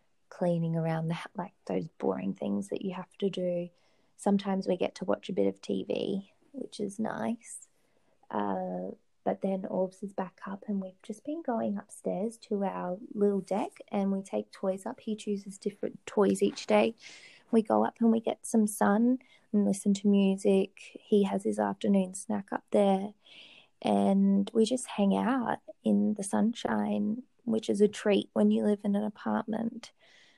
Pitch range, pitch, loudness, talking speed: 190-220 Hz, 205 Hz, -31 LUFS, 175 wpm